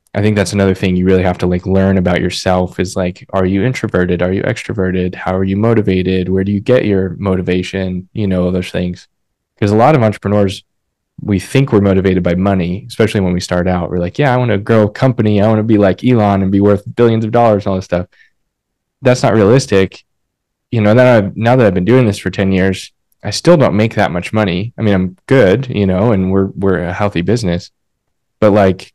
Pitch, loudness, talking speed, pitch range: 95 Hz, -13 LUFS, 235 wpm, 95-110 Hz